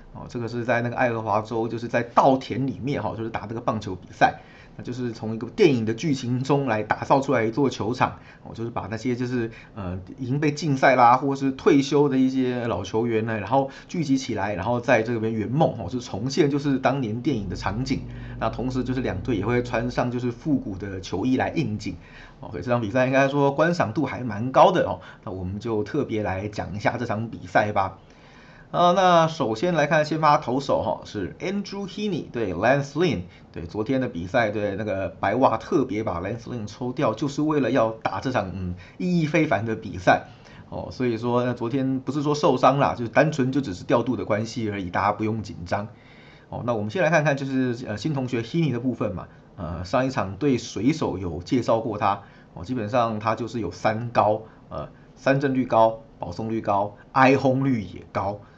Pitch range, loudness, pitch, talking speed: 110-135 Hz, -24 LUFS, 120 Hz, 335 characters per minute